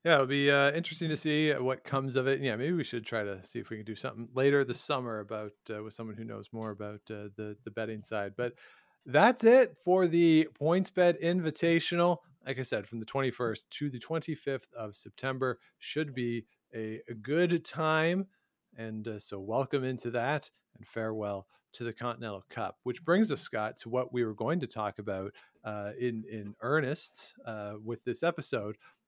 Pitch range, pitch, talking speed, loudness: 110-155 Hz, 125 Hz, 200 wpm, -31 LUFS